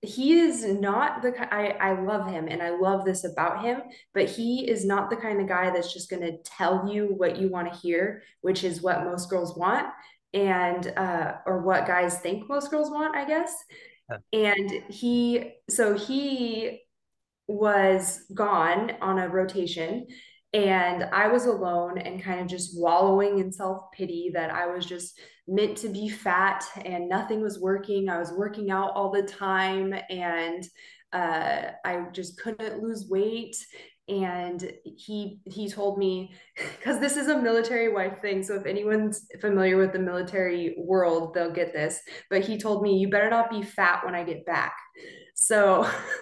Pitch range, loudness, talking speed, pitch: 180-215 Hz, -27 LUFS, 175 wpm, 195 Hz